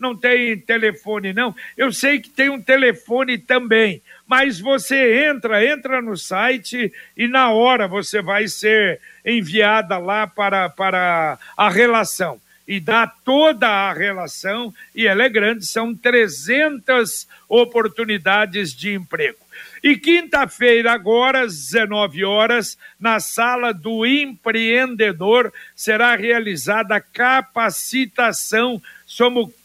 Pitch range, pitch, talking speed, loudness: 205-250 Hz, 230 Hz, 115 wpm, -17 LUFS